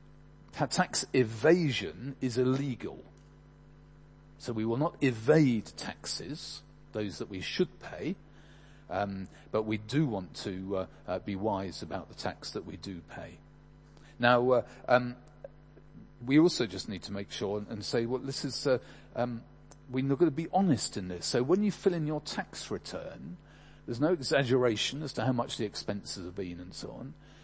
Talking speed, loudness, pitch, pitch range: 170 wpm, -31 LUFS, 125 Hz, 100-145 Hz